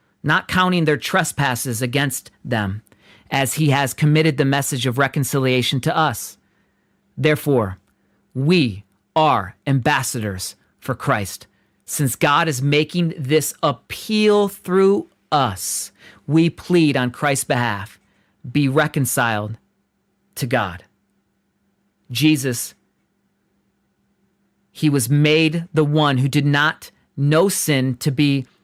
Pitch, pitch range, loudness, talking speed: 140 Hz, 125-155 Hz, -19 LUFS, 110 wpm